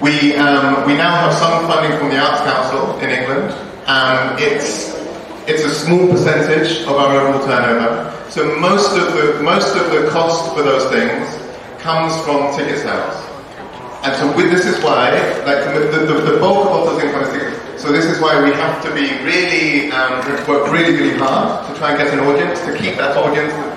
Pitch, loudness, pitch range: 150 Hz, -14 LUFS, 140-160 Hz